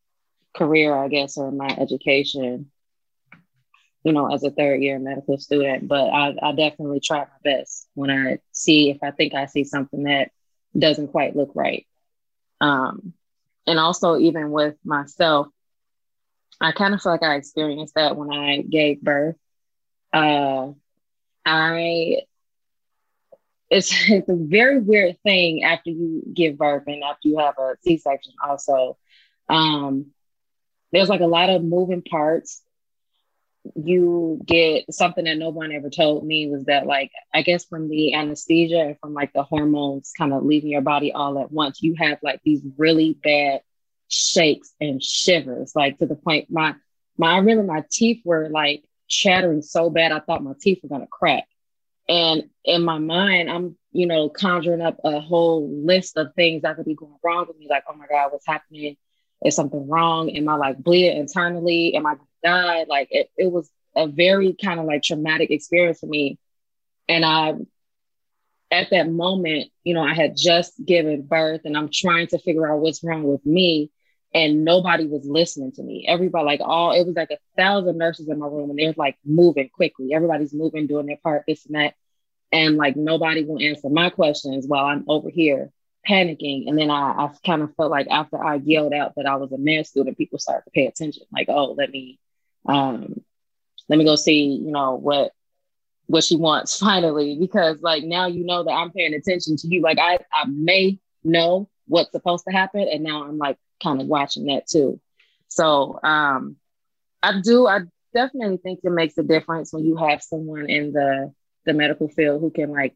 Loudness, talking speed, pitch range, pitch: -20 LUFS, 180 wpm, 145-170 Hz, 155 Hz